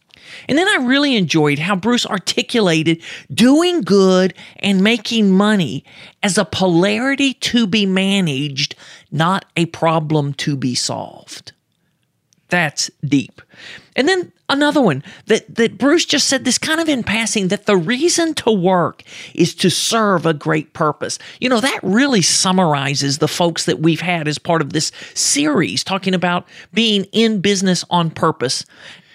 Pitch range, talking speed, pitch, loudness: 160-230 Hz, 150 wpm, 190 Hz, -16 LUFS